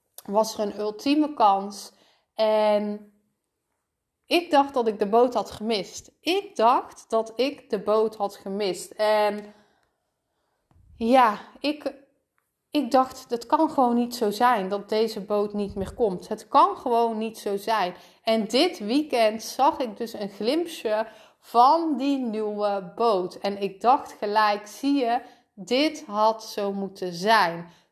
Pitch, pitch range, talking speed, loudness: 220 Hz, 205-250 Hz, 145 wpm, -24 LUFS